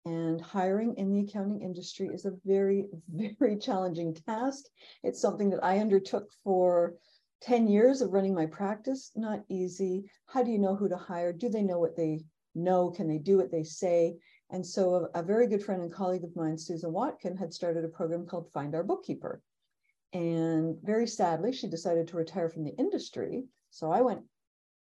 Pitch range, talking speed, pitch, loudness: 170-210 Hz, 190 wpm, 185 Hz, -31 LUFS